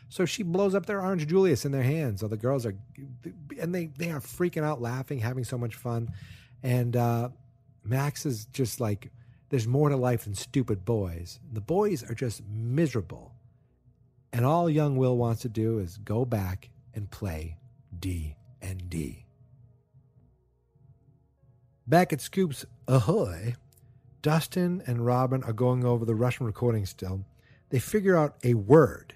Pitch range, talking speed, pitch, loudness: 115-140 Hz, 160 wpm, 125 Hz, -28 LUFS